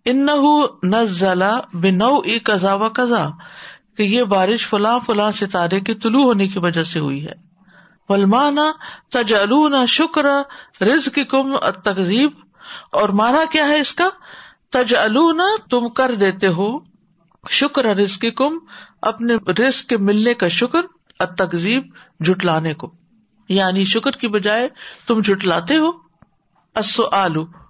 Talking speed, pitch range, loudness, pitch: 120 wpm, 190-265 Hz, -17 LUFS, 220 Hz